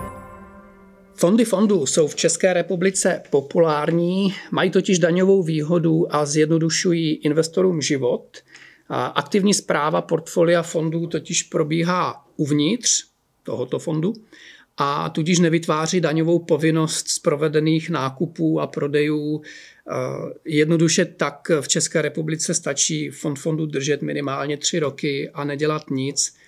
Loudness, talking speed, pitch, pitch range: -20 LUFS, 110 wpm, 160 Hz, 150-175 Hz